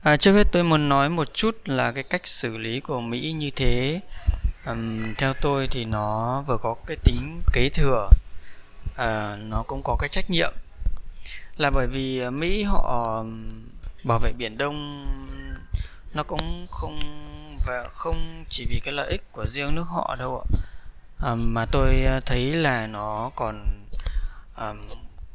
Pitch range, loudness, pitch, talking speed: 95-140 Hz, -26 LUFS, 120 Hz, 160 wpm